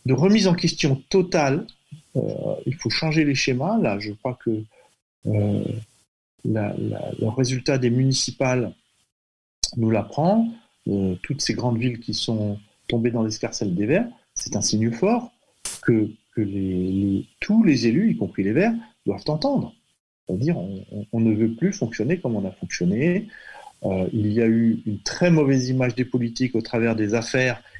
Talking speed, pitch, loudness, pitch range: 175 wpm, 120 Hz, -23 LUFS, 110-150 Hz